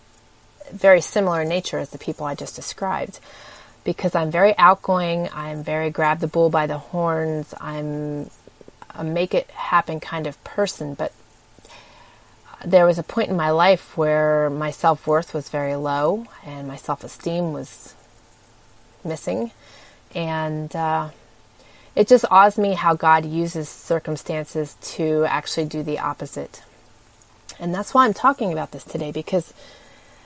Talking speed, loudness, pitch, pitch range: 145 wpm, -21 LUFS, 155 Hz, 145-175 Hz